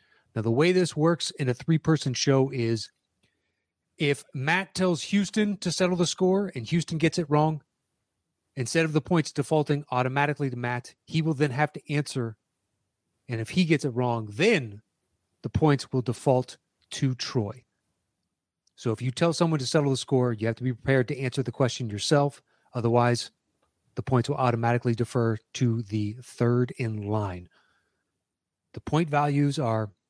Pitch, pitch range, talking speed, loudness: 130 Hz, 115-150 Hz, 170 wpm, -26 LUFS